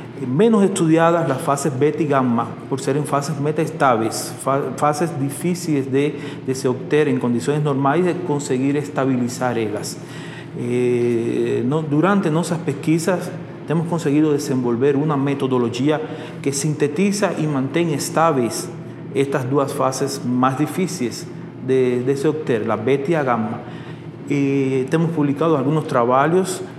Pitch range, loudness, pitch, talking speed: 135-160 Hz, -19 LUFS, 145 Hz, 130 wpm